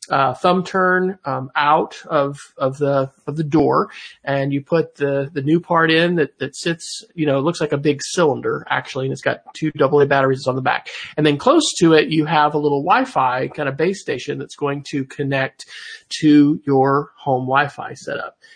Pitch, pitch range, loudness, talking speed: 145 Hz, 140-165 Hz, -18 LUFS, 200 wpm